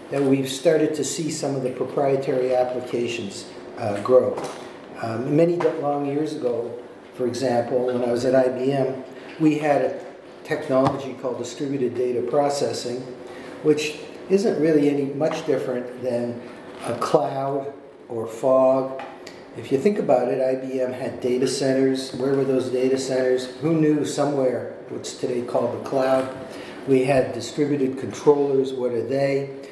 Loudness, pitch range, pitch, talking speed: -23 LUFS, 125-140 Hz, 130 Hz, 145 wpm